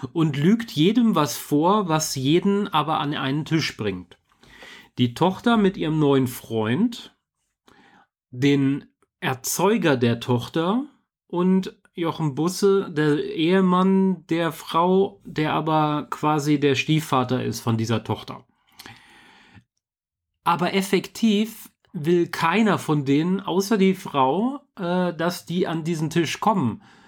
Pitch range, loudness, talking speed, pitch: 140-190 Hz, -22 LUFS, 115 wpm, 165 Hz